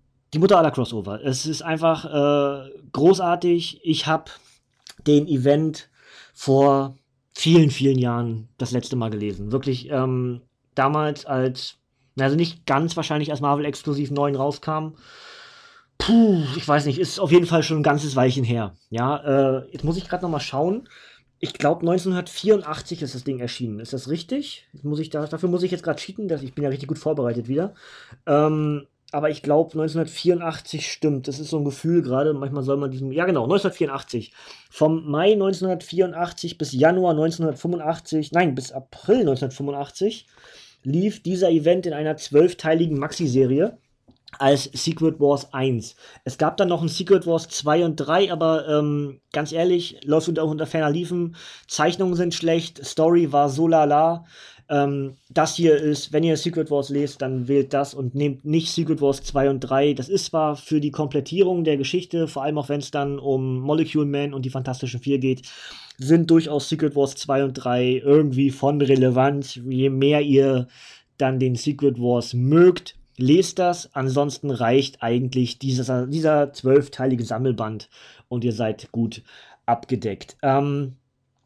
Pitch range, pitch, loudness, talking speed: 135-165 Hz, 145 Hz, -22 LUFS, 165 wpm